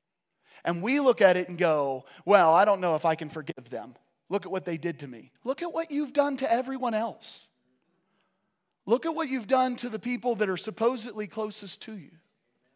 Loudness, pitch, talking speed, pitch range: -27 LUFS, 200 Hz, 210 wpm, 175-245 Hz